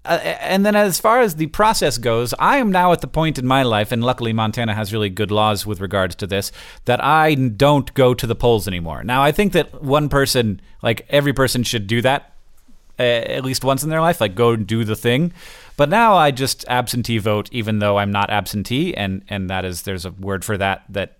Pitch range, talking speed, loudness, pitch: 105-145 Hz, 230 wpm, -18 LUFS, 120 Hz